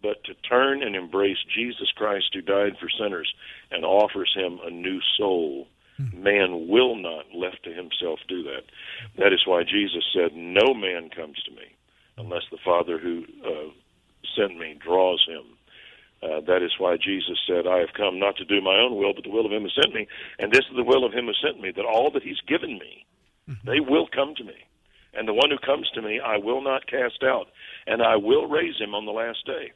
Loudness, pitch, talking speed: -24 LUFS, 100 Hz, 220 wpm